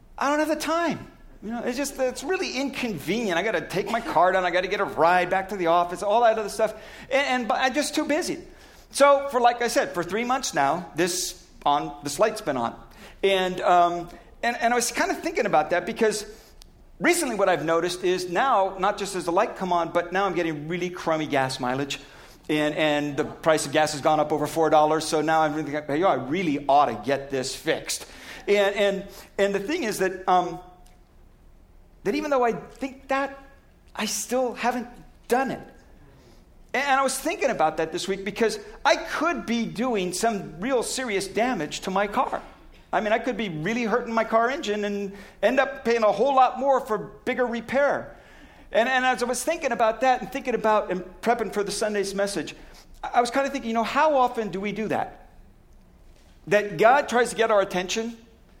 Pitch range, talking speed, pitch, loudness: 180-250 Hz, 215 wpm, 210 Hz, -24 LUFS